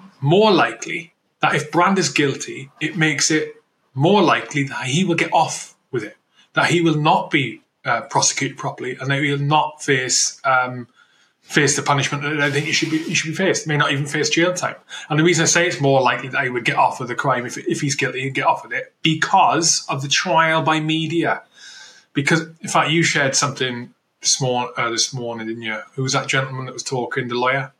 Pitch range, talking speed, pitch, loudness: 130-160 Hz, 230 wpm, 145 Hz, -19 LUFS